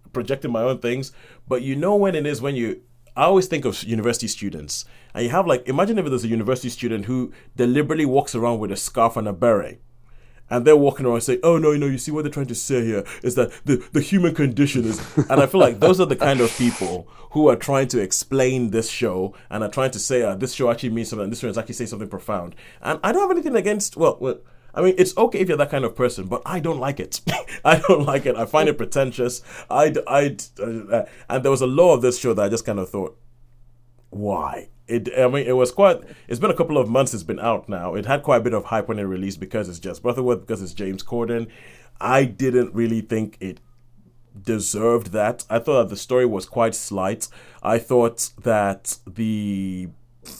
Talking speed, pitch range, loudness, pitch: 235 wpm, 115-135 Hz, -21 LUFS, 120 Hz